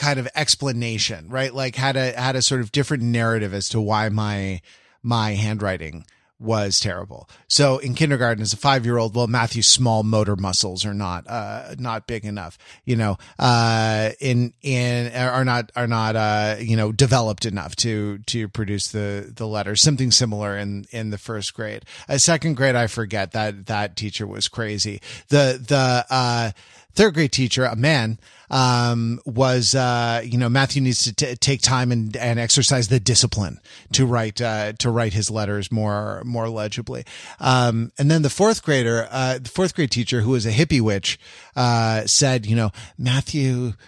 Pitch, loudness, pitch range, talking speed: 120 Hz, -20 LUFS, 105-130 Hz, 175 wpm